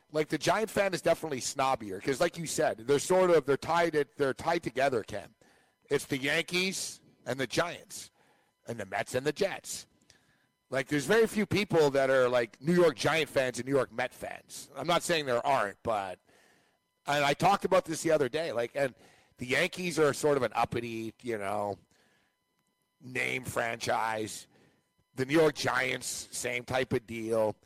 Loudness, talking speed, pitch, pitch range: -30 LUFS, 185 wpm, 140 Hz, 125-165 Hz